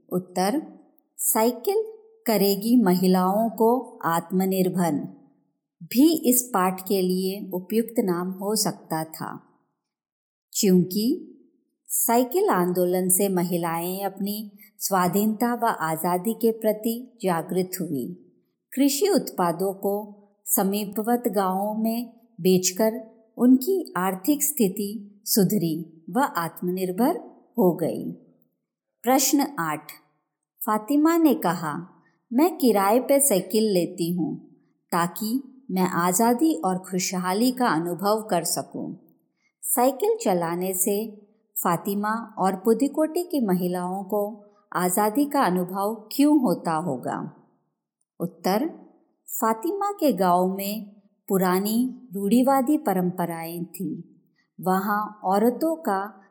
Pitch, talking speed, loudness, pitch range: 205 Hz, 95 wpm, -24 LUFS, 180-240 Hz